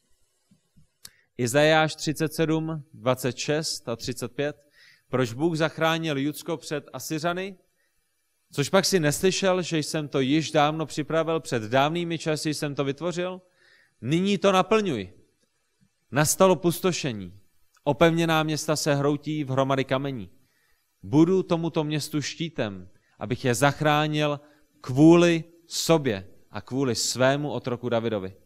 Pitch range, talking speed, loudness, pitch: 130-165 Hz, 110 wpm, -25 LUFS, 150 Hz